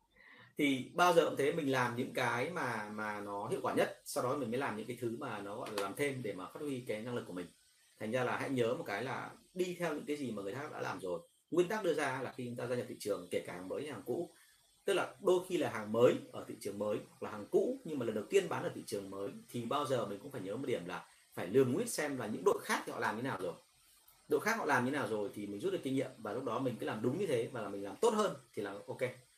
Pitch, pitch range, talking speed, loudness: 125 Hz, 105-145 Hz, 320 wpm, -37 LUFS